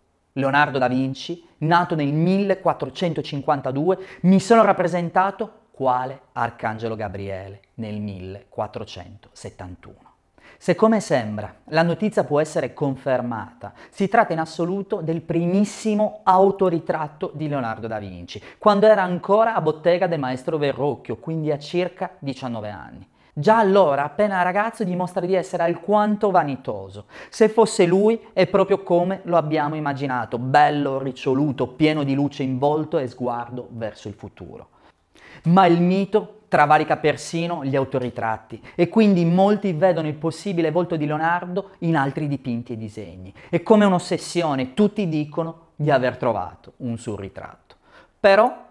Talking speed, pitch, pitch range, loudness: 135 wpm, 155 Hz, 125-185 Hz, -21 LUFS